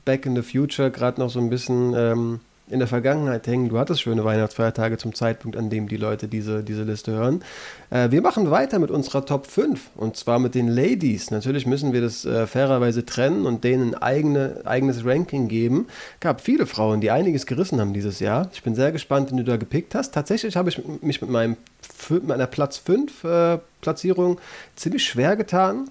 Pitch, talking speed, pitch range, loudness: 125 Hz, 205 wpm, 115-145 Hz, -22 LUFS